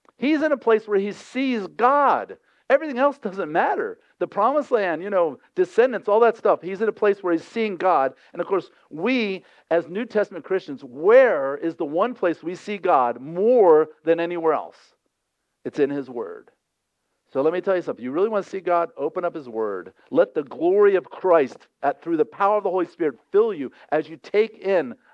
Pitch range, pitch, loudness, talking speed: 175-295 Hz, 210 Hz, -22 LUFS, 210 wpm